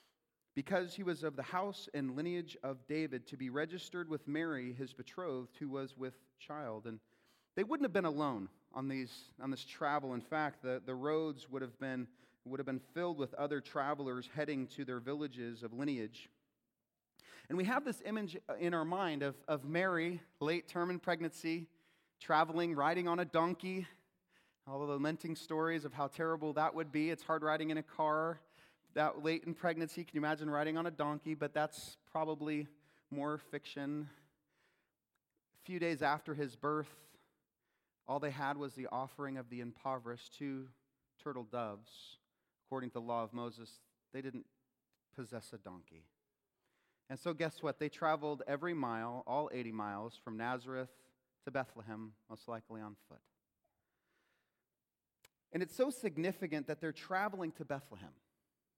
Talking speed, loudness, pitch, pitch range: 165 wpm, -40 LUFS, 145 Hz, 130-160 Hz